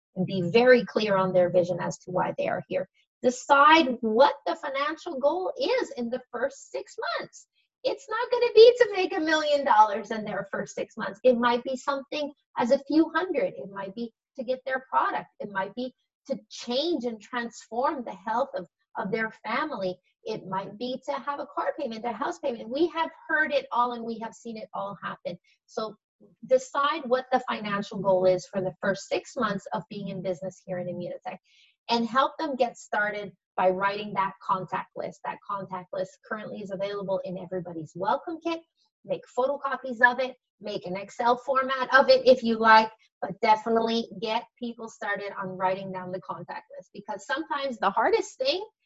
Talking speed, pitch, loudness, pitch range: 195 wpm, 240 Hz, -26 LUFS, 195-280 Hz